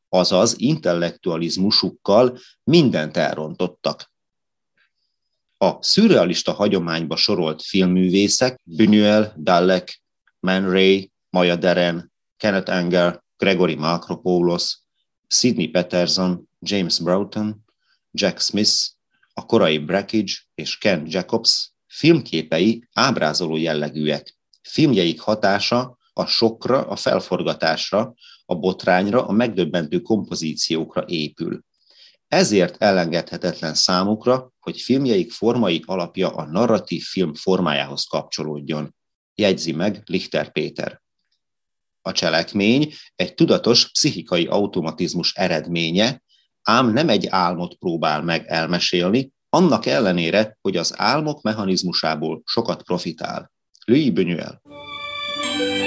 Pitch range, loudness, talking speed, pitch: 85-105 Hz, -19 LUFS, 90 wpm, 95 Hz